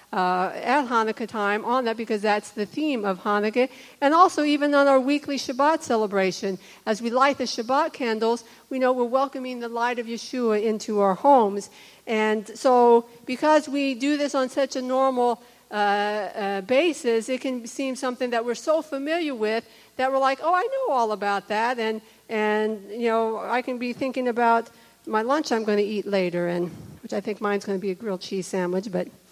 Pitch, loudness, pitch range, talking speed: 235 Hz, -24 LUFS, 210-265 Hz, 200 wpm